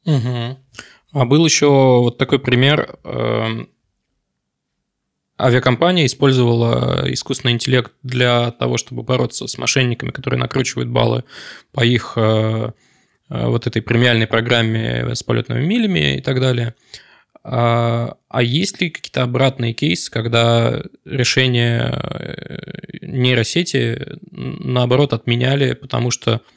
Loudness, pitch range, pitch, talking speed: -17 LUFS, 115-135 Hz, 125 Hz, 105 wpm